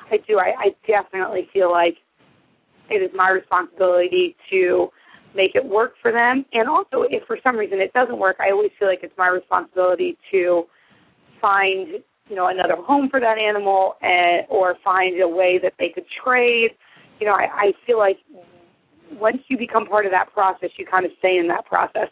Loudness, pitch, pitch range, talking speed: -19 LUFS, 195 Hz, 185-240 Hz, 195 wpm